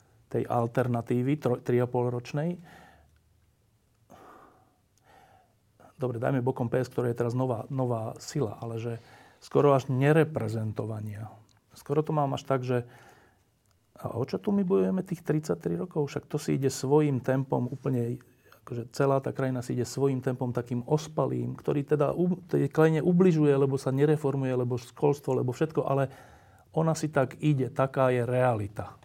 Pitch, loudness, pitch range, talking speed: 130 Hz, -28 LUFS, 120-145 Hz, 145 wpm